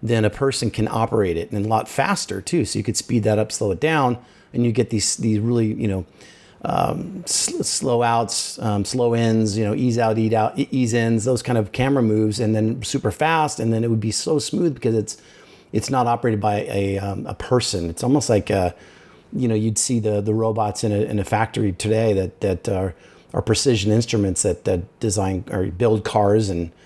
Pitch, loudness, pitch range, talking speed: 110 Hz, -21 LUFS, 105-120 Hz, 220 wpm